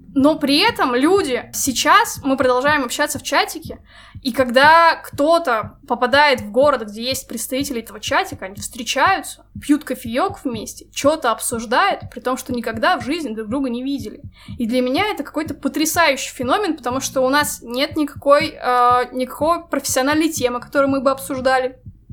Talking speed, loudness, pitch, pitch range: 155 wpm, -18 LUFS, 275 Hz, 250-295 Hz